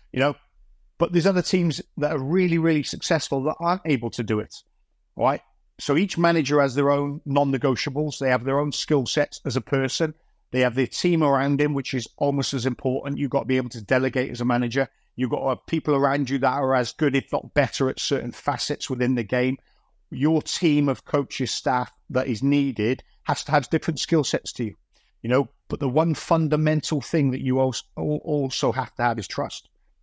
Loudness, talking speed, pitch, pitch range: -24 LUFS, 215 wpm, 140 Hz, 130-150 Hz